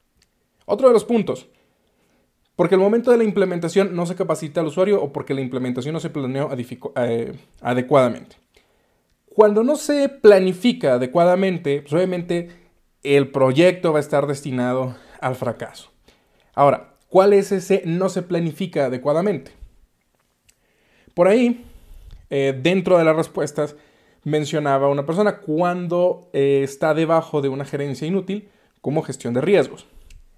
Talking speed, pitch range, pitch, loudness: 140 wpm, 140-190 Hz, 165 Hz, -19 LUFS